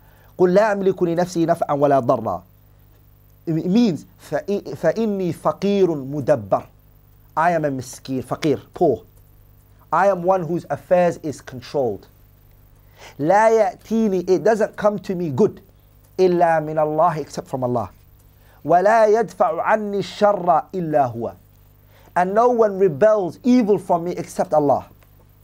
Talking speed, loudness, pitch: 125 wpm, -19 LUFS, 155 Hz